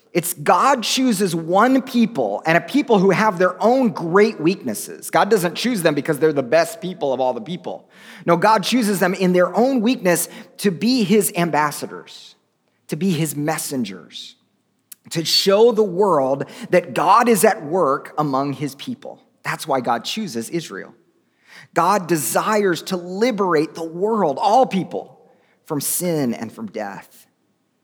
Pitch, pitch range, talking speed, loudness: 185 Hz, 165-220 Hz, 155 wpm, -18 LUFS